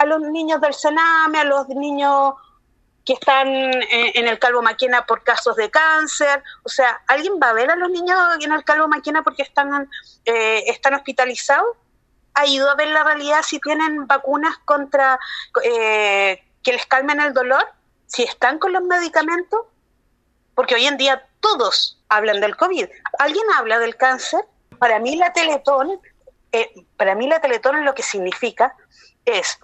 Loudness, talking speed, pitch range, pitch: -17 LUFS, 165 wpm, 255-325 Hz, 285 Hz